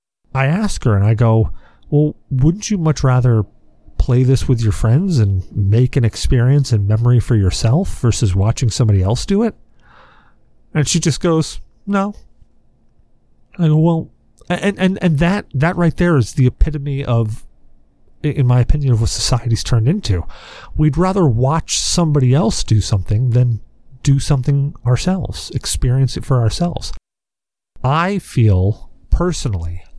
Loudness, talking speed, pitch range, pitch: -16 LUFS, 150 wpm, 110-160 Hz, 130 Hz